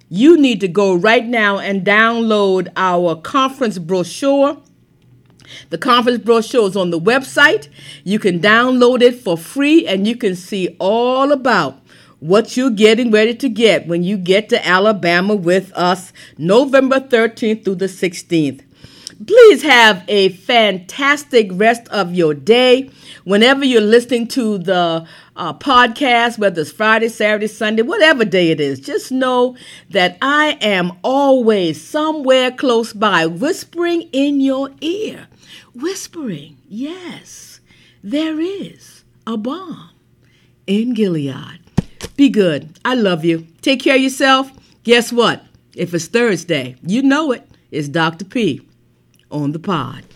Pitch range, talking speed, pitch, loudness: 180-260 Hz, 140 wpm, 220 Hz, -14 LUFS